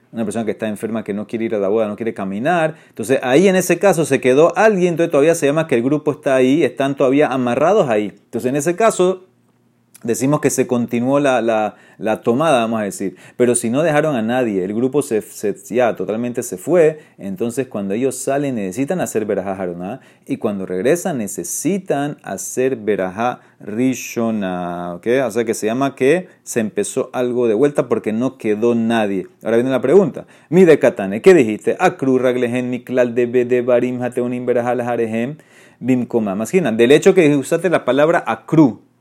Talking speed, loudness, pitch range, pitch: 175 wpm, -17 LUFS, 115-140 Hz, 125 Hz